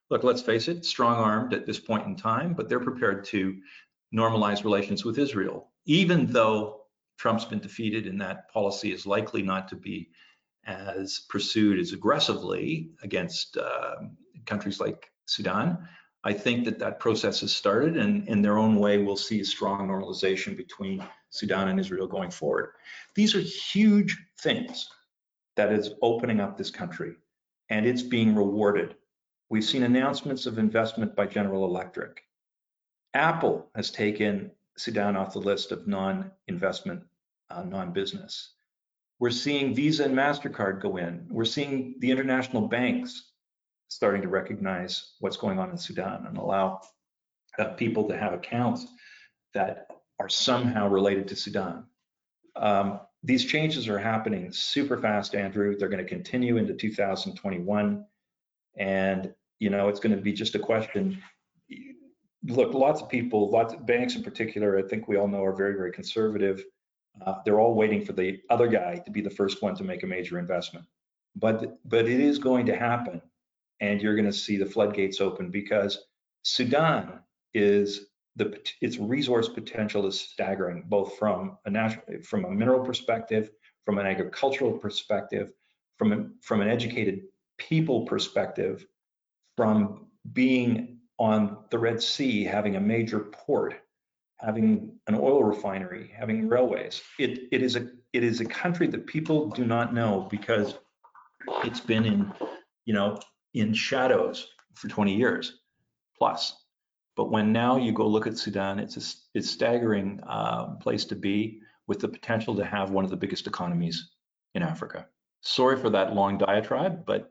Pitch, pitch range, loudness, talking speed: 110 Hz, 100-140 Hz, -27 LUFS, 155 wpm